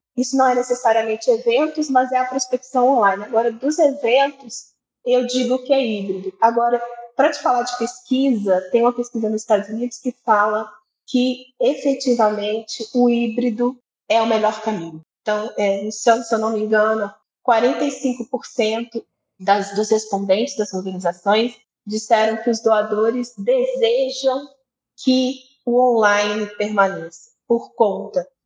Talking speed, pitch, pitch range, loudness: 140 wpm, 235 Hz, 215-255 Hz, -19 LUFS